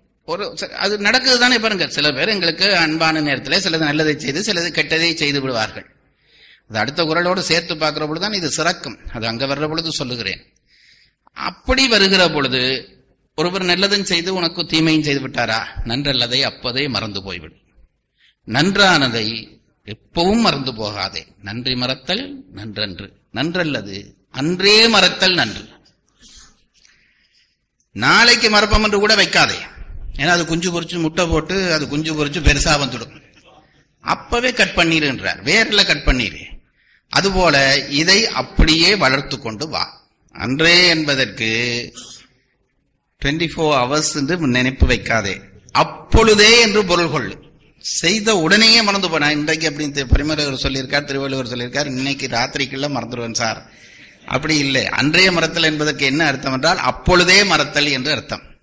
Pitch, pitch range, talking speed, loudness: 150 Hz, 125-175 Hz, 125 wpm, -15 LUFS